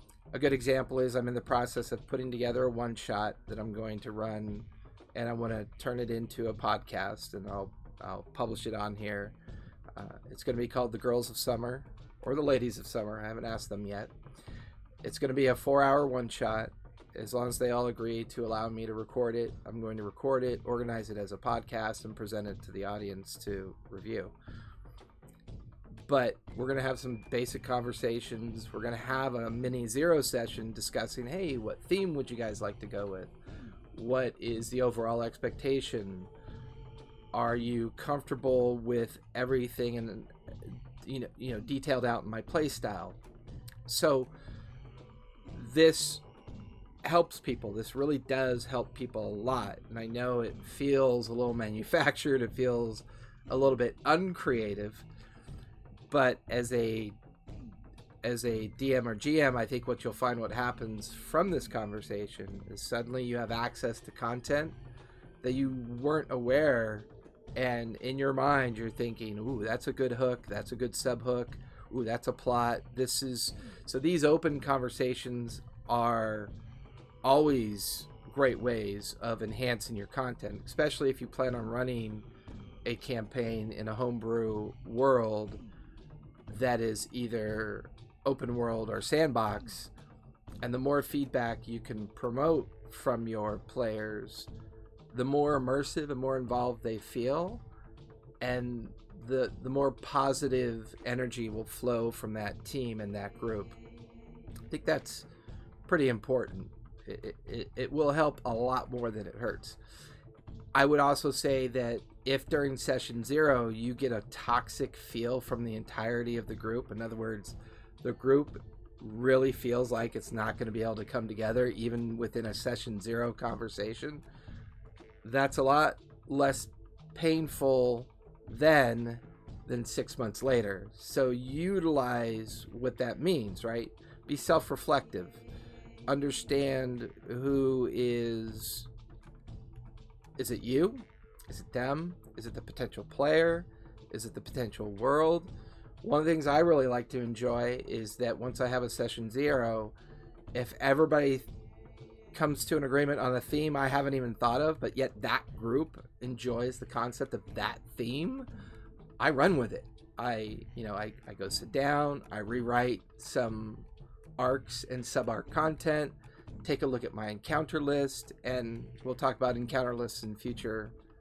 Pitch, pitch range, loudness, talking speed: 120 Hz, 110-130 Hz, -33 LUFS, 155 wpm